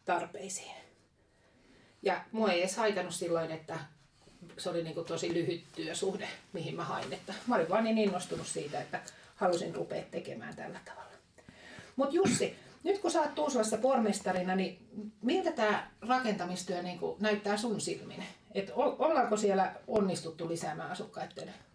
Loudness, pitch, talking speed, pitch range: -34 LUFS, 195 Hz, 140 wpm, 175-220 Hz